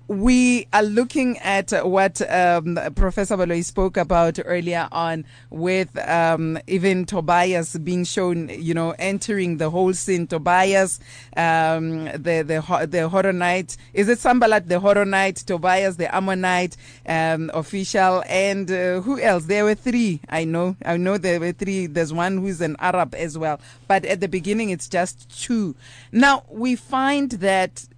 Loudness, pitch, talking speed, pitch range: -21 LUFS, 180 Hz, 155 wpm, 165-195 Hz